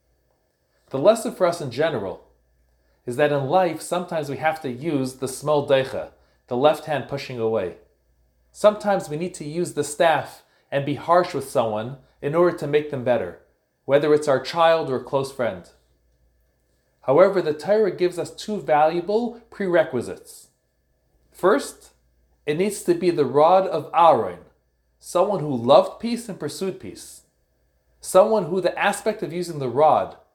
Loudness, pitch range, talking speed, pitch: -22 LUFS, 110-175 Hz, 160 wpm, 150 Hz